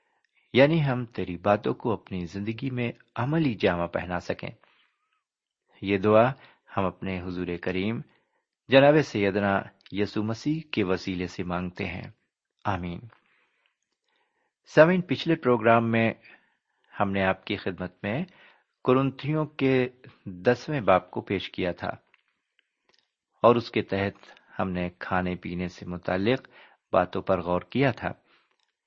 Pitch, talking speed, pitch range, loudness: 110 Hz, 125 wpm, 95-135 Hz, -26 LUFS